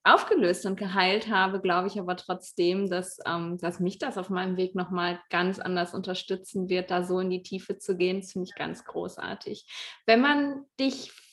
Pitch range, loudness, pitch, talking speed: 180-200 Hz, -28 LUFS, 185 Hz, 185 wpm